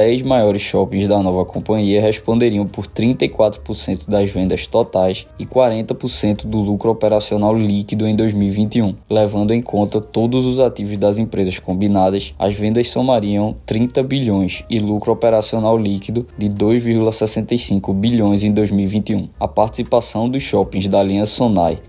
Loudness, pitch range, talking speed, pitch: -17 LUFS, 100-115 Hz, 135 wpm, 105 Hz